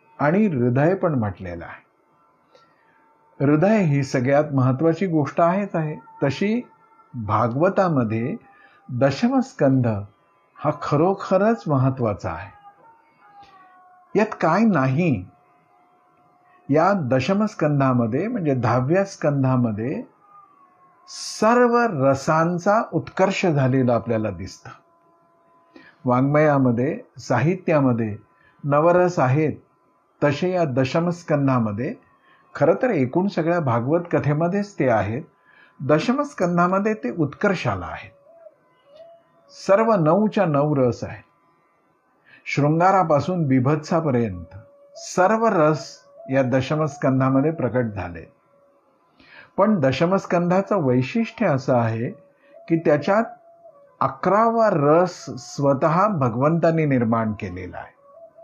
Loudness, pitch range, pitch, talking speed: -21 LUFS, 130-205 Hz, 160 Hz, 80 wpm